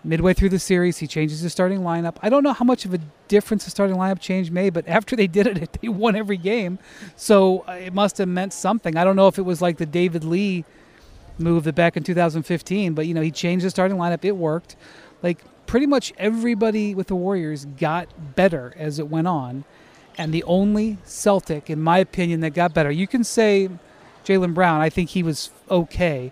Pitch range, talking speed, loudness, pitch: 165-195 Hz, 215 wpm, -21 LUFS, 180 Hz